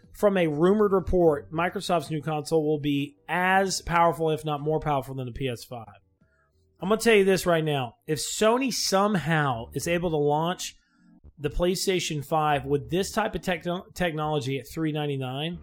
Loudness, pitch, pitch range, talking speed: -25 LUFS, 155 Hz, 145-180 Hz, 170 wpm